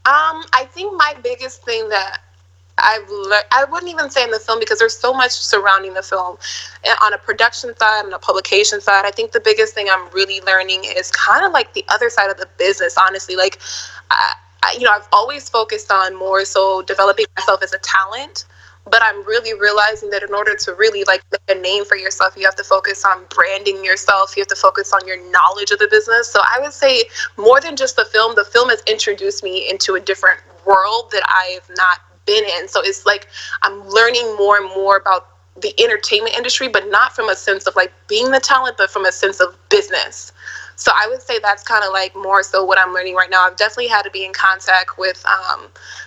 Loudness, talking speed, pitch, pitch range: -15 LUFS, 225 wpm, 210 Hz, 190-275 Hz